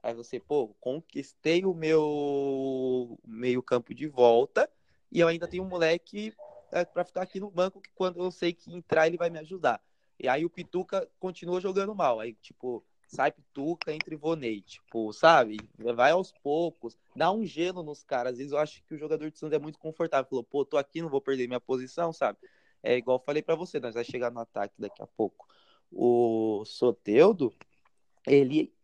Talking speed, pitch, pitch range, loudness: 195 wpm, 155 Hz, 125-175 Hz, -29 LUFS